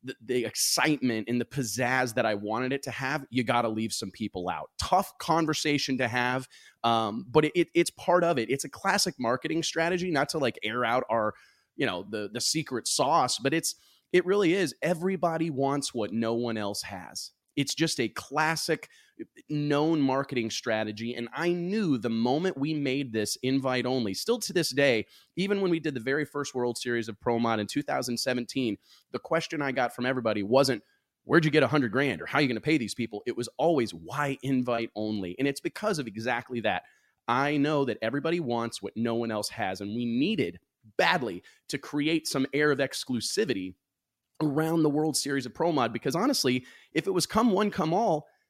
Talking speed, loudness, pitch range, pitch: 205 wpm, -28 LUFS, 115-155 Hz, 130 Hz